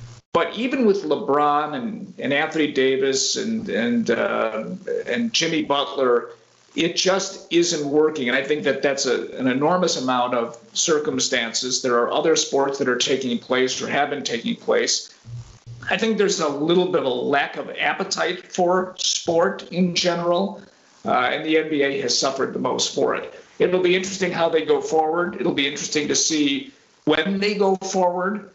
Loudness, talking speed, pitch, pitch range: -21 LUFS, 175 wpm, 170 Hz, 140-195 Hz